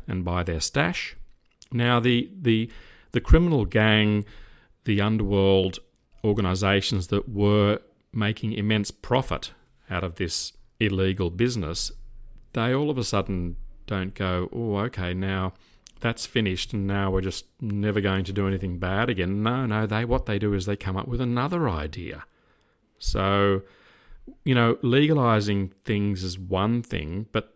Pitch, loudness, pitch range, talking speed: 100 Hz, -25 LUFS, 95-115 Hz, 150 wpm